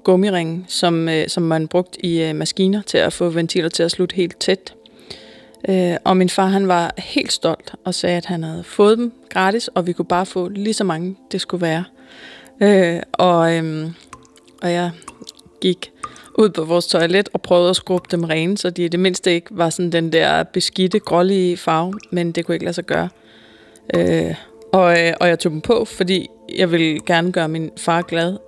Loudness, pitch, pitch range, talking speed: -18 LUFS, 175 Hz, 165-190 Hz, 205 wpm